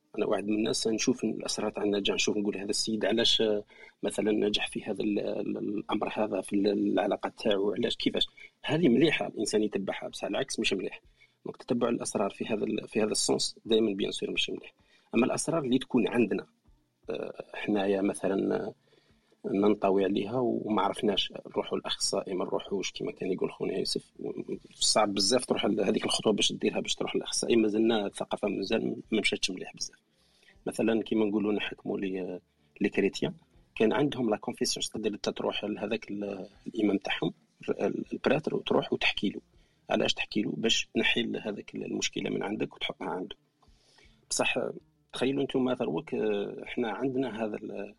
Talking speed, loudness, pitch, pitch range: 145 wpm, -30 LUFS, 105 Hz, 100-110 Hz